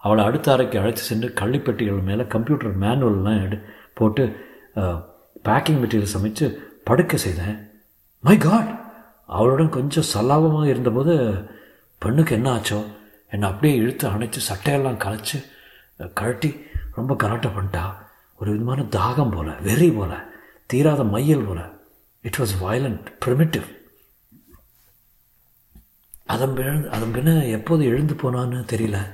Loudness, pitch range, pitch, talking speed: -21 LUFS, 105-140 Hz, 120 Hz, 115 wpm